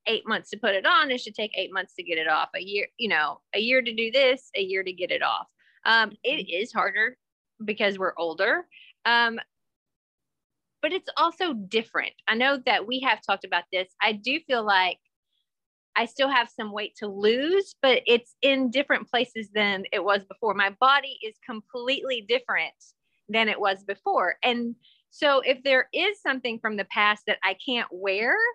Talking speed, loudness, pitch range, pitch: 195 wpm, -25 LUFS, 200-270 Hz, 225 Hz